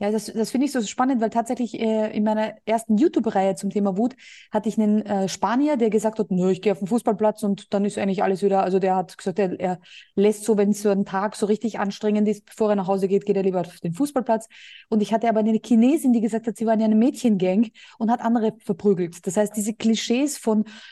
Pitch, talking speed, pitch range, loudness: 215 Hz, 250 wpm, 200-230 Hz, -22 LUFS